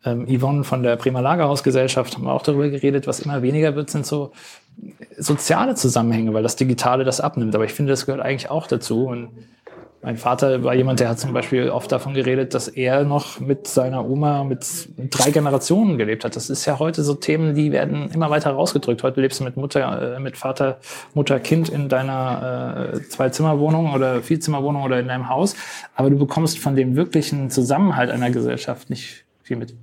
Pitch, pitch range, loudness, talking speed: 135 Hz, 125-145 Hz, -20 LUFS, 195 wpm